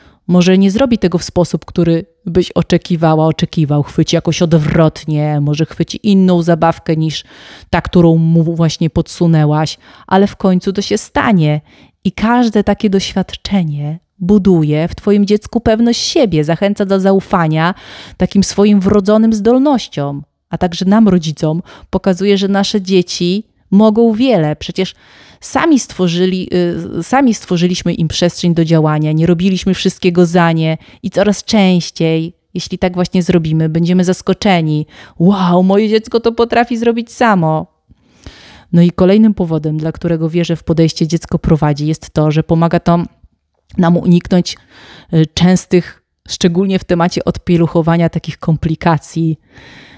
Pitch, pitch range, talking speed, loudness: 175 Hz, 165-195 Hz, 135 wpm, -13 LUFS